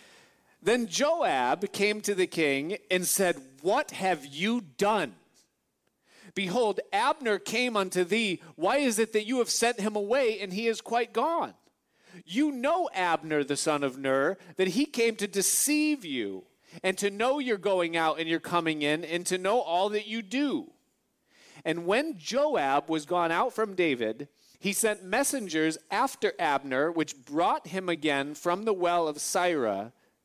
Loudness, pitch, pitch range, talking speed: -28 LUFS, 195 Hz, 165-230 Hz, 165 wpm